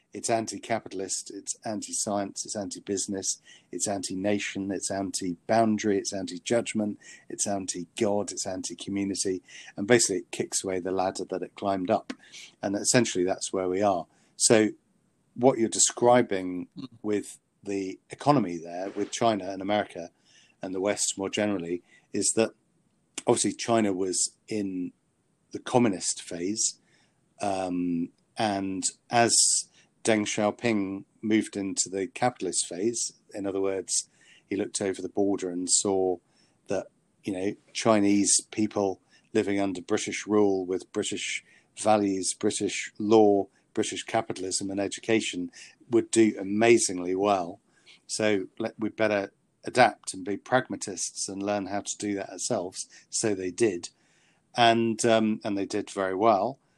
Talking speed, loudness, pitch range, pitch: 140 wpm, -27 LUFS, 95-110 Hz, 100 Hz